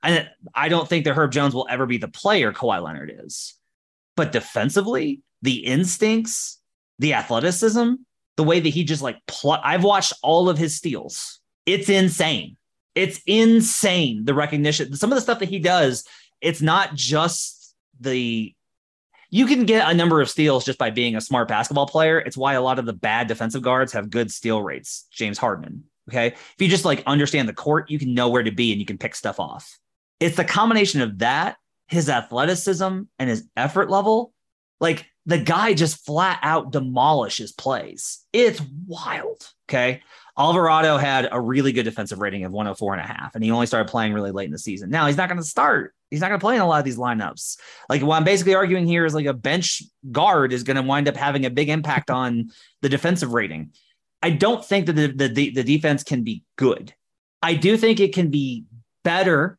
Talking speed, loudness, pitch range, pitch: 200 wpm, -21 LUFS, 125-180 Hz, 150 Hz